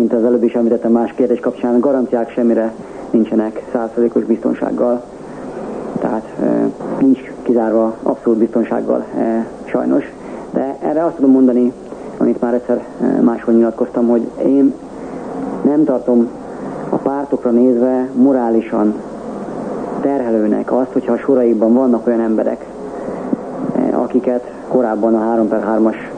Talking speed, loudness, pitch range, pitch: 110 wpm, -16 LUFS, 115-125 Hz, 120 Hz